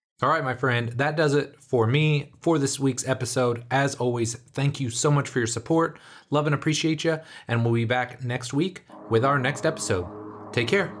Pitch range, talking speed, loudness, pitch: 120-150 Hz, 205 wpm, -25 LUFS, 135 Hz